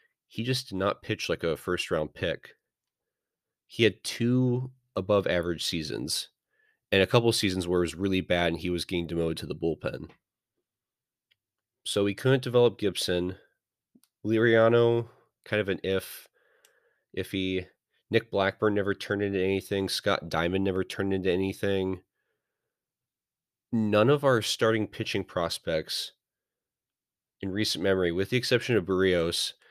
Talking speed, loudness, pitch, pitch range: 145 wpm, -27 LUFS, 95 Hz, 95-115 Hz